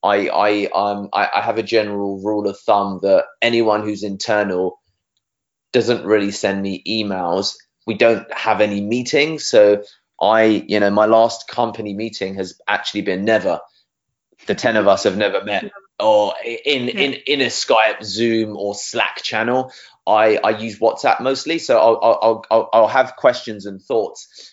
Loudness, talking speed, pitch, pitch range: -17 LUFS, 165 wpm, 110 Hz, 100-115 Hz